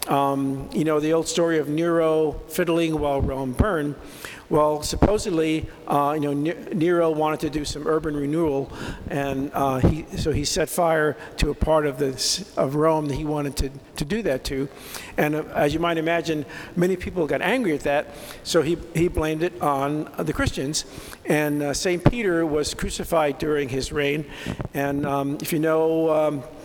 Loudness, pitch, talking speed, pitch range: -23 LUFS, 155 Hz, 180 wpm, 145-160 Hz